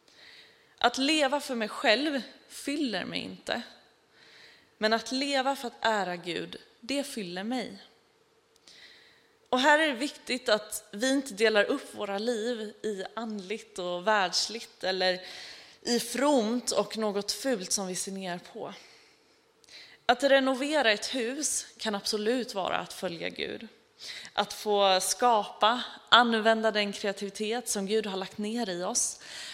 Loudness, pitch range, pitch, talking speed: -29 LUFS, 205-265 Hz, 225 Hz, 140 wpm